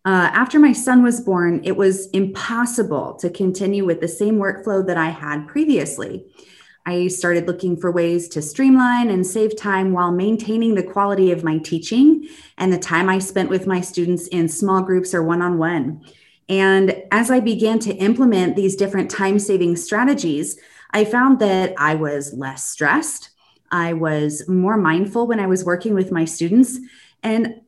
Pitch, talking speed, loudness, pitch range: 190 Hz, 170 wpm, -18 LUFS, 175-220 Hz